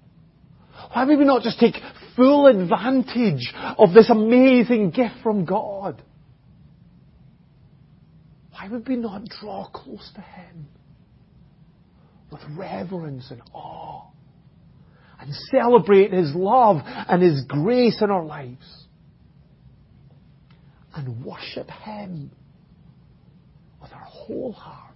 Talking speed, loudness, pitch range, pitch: 105 wpm, -18 LUFS, 150-225 Hz, 170 Hz